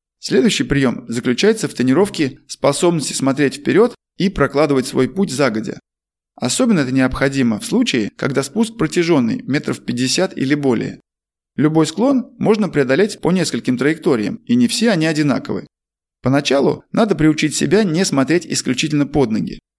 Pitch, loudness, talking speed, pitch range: 155 Hz, -17 LUFS, 140 wpm, 135-200 Hz